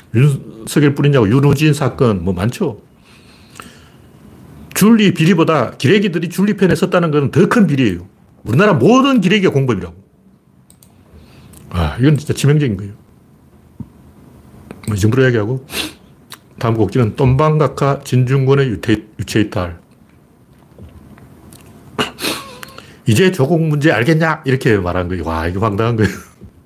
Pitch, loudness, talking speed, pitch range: 135 Hz, -14 LUFS, 265 characters per minute, 110-160 Hz